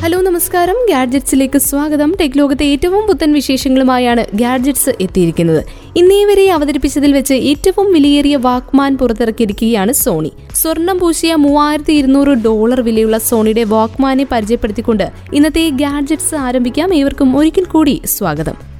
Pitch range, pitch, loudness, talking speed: 240-315 Hz, 280 Hz, -12 LUFS, 110 wpm